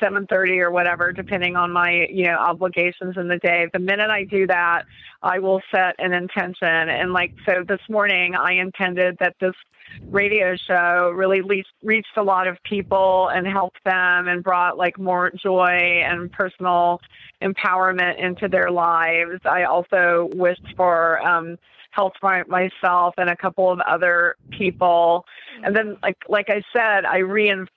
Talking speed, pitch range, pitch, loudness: 160 wpm, 175-190 Hz, 185 Hz, -19 LUFS